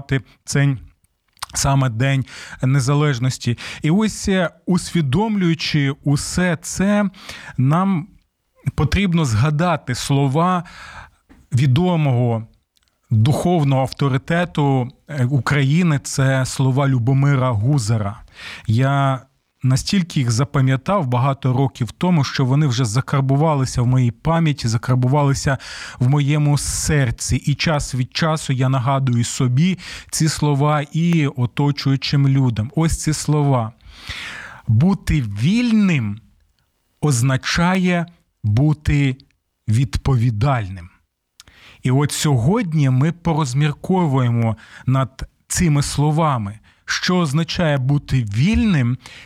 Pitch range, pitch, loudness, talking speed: 125-155 Hz, 140 Hz, -18 LUFS, 85 wpm